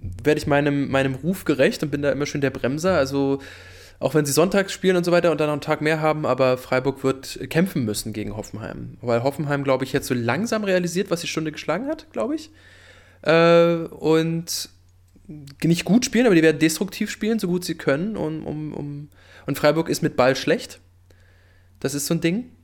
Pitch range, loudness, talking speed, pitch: 130-170 Hz, -22 LUFS, 205 wpm, 150 Hz